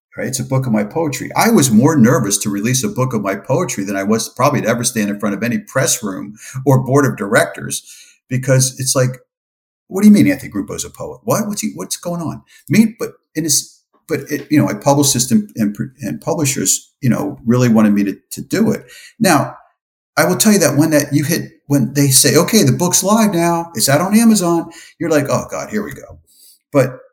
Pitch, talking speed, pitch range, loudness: 140 Hz, 235 wpm, 120-175 Hz, -15 LUFS